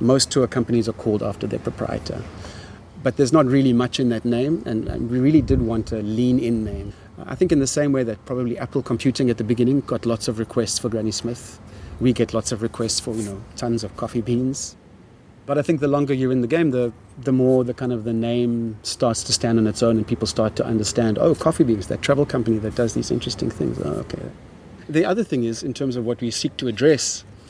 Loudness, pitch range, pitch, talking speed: -21 LUFS, 110-130 Hz, 120 Hz, 240 wpm